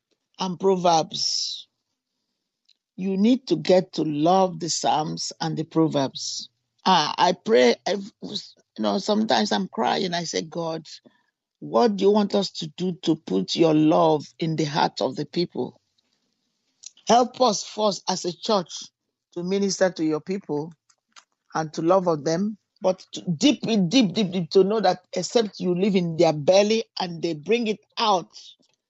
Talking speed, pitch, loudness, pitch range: 160 wpm, 180 Hz, -23 LUFS, 160-205 Hz